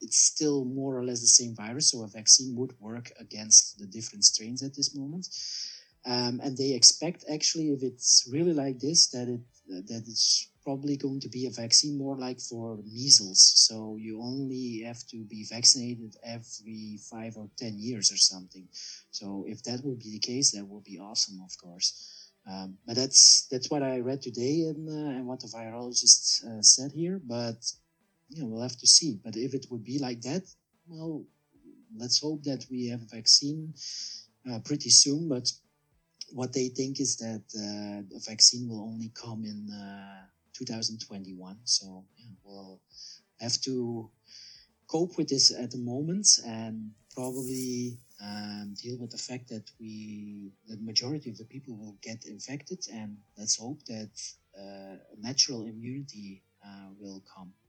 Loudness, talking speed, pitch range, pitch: -24 LUFS, 170 wpm, 110-135 Hz, 120 Hz